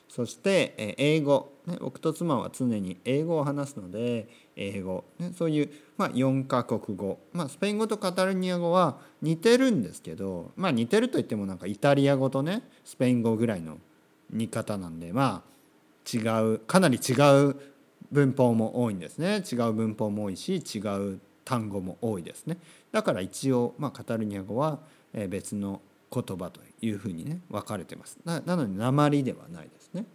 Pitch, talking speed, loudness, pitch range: 130 Hz, 315 characters per minute, -28 LUFS, 105-160 Hz